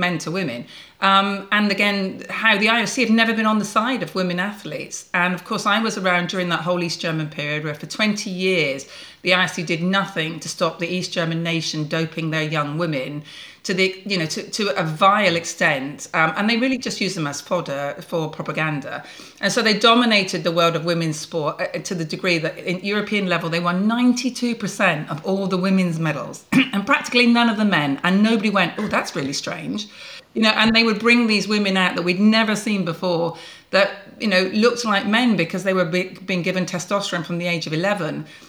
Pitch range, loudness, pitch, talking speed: 170-210 Hz, -20 LUFS, 185 Hz, 215 wpm